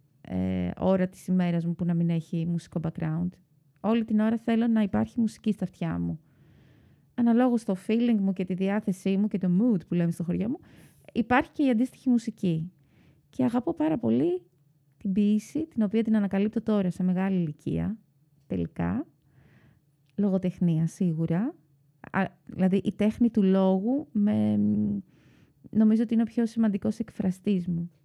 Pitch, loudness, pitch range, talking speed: 195 Hz, -27 LUFS, 170-225 Hz, 160 wpm